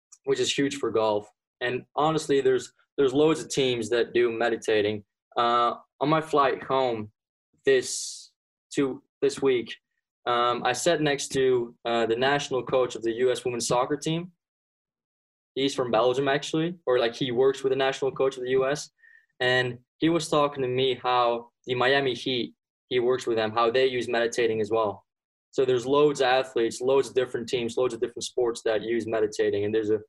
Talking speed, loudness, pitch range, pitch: 185 wpm, -26 LUFS, 120-160 Hz, 130 Hz